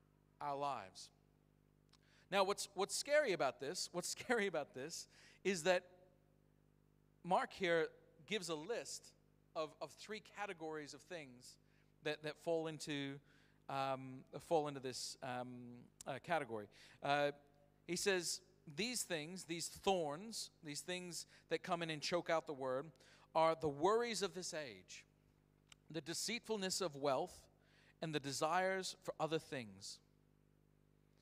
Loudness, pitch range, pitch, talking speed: -42 LUFS, 145-185 Hz, 160 Hz, 135 wpm